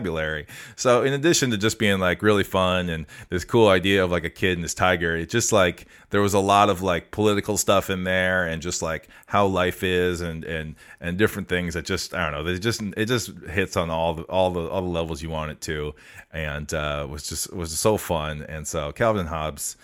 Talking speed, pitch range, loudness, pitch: 235 wpm, 80-100 Hz, -23 LUFS, 90 Hz